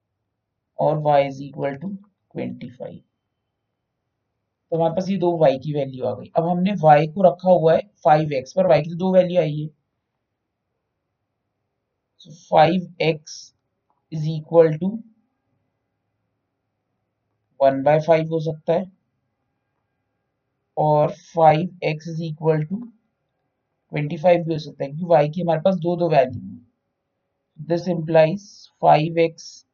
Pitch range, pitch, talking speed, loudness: 125-165 Hz, 150 Hz, 135 wpm, -20 LUFS